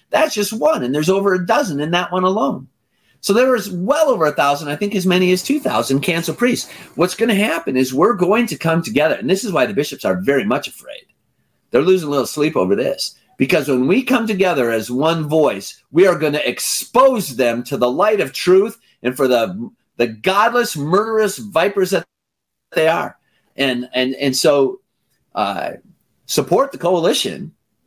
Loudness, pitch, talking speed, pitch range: -17 LUFS, 185 Hz, 195 wpm, 145-215 Hz